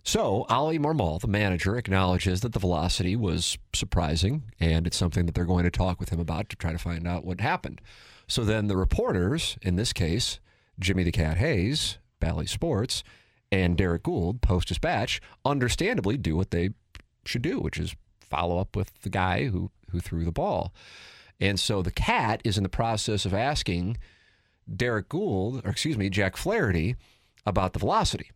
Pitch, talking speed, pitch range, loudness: 95 Hz, 180 wpm, 85-105 Hz, -27 LUFS